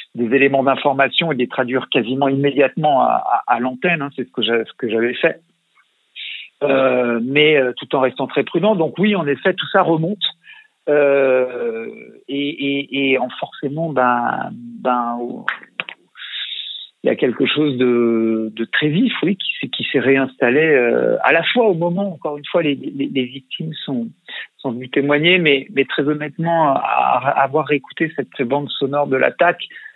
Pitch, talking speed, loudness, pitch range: 140 Hz, 175 wpm, -17 LUFS, 130-170 Hz